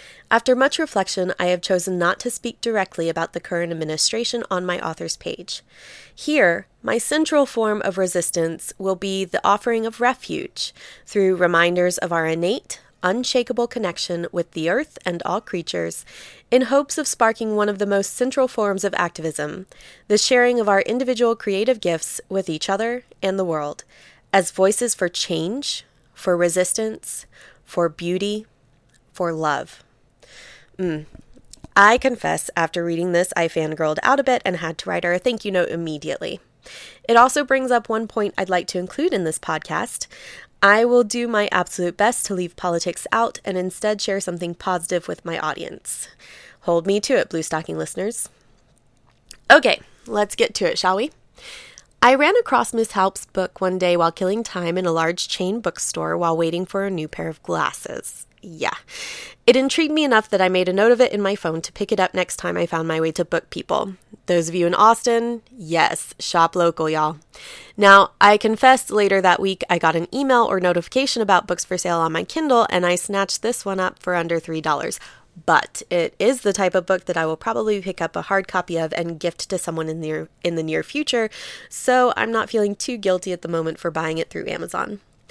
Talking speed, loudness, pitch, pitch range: 195 wpm, -20 LUFS, 190 Hz, 170-225 Hz